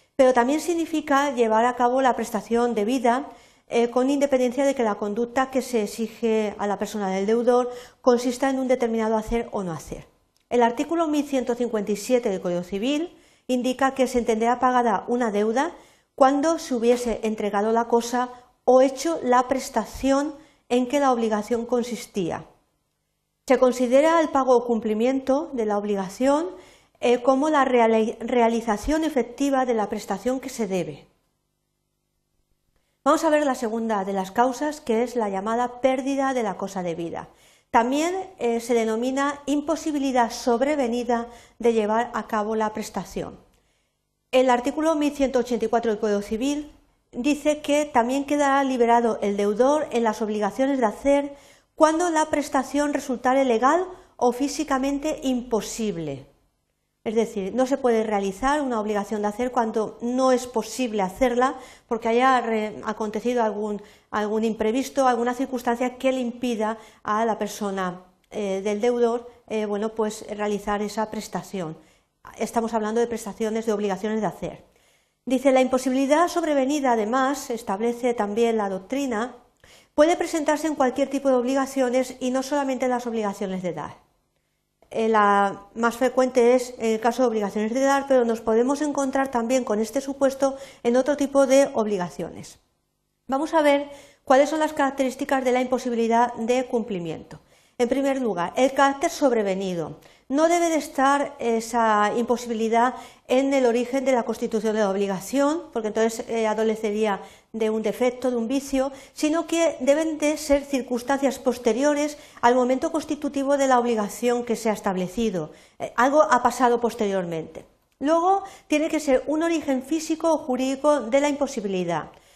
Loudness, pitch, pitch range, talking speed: -23 LUFS, 245 Hz, 220-275 Hz, 150 wpm